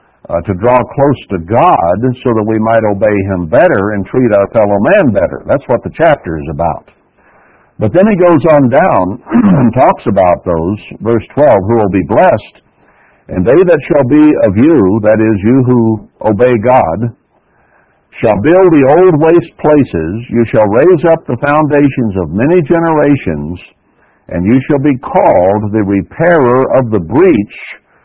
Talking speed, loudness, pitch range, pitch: 170 wpm, -9 LUFS, 105-150 Hz, 120 Hz